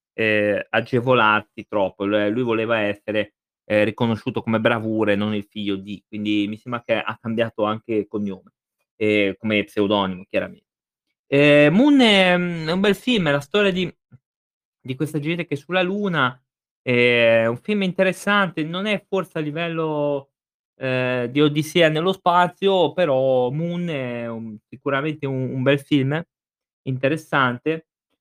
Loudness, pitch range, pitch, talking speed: -20 LUFS, 110-165 Hz, 130 Hz, 155 wpm